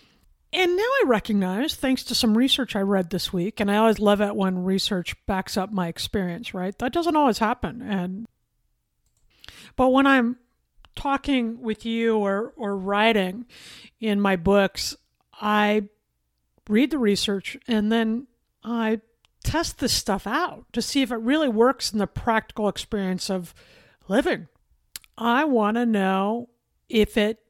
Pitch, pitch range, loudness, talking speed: 220 Hz, 200-245 Hz, -23 LUFS, 155 wpm